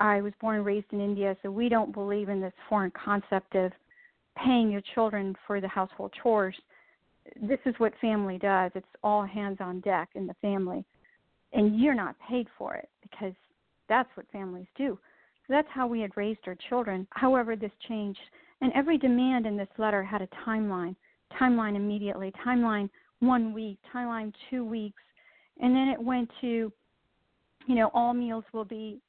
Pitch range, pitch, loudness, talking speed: 200-245 Hz, 215 Hz, -30 LUFS, 175 wpm